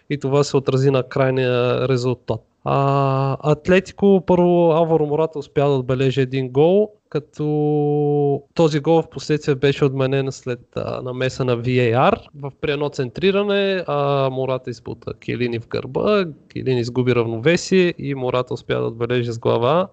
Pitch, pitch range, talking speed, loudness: 140 Hz, 130-155 Hz, 145 wpm, -19 LUFS